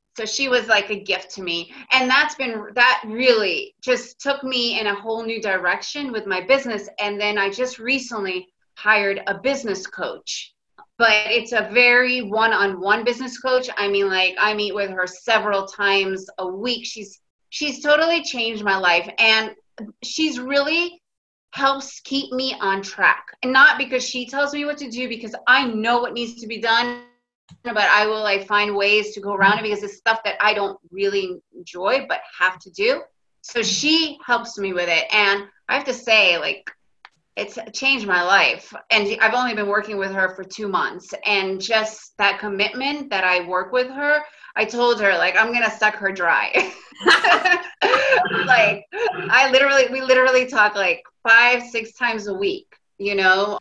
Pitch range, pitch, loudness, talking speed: 200-255 Hz, 225 Hz, -19 LUFS, 185 wpm